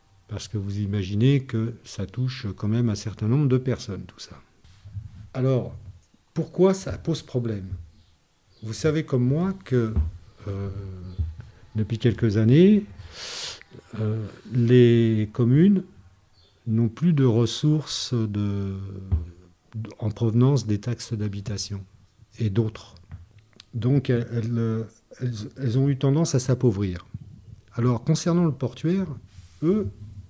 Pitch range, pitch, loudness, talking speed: 100-125 Hz, 110 Hz, -24 LUFS, 120 wpm